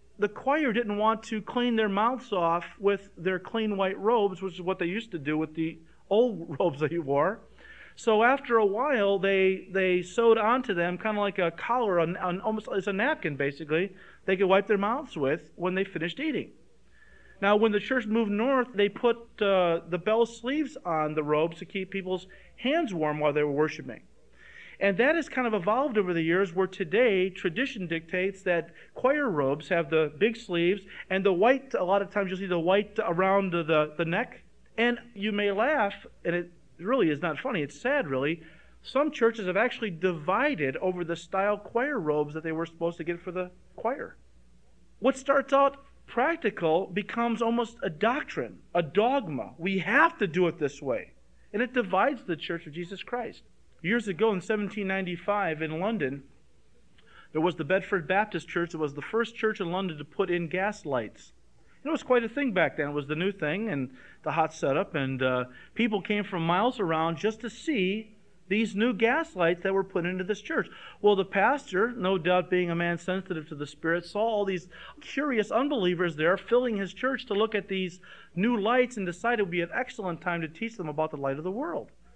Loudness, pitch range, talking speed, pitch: -28 LUFS, 170-225 Hz, 205 wpm, 195 Hz